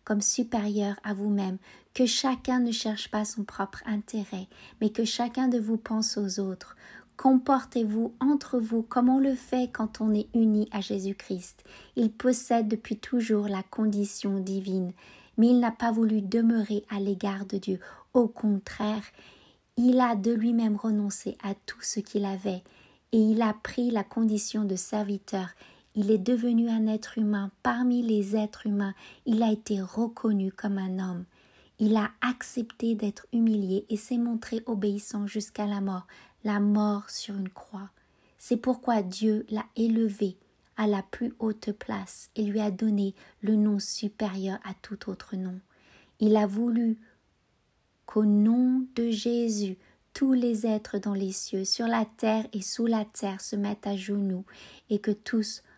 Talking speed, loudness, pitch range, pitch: 170 wpm, -28 LUFS, 205-230 Hz, 215 Hz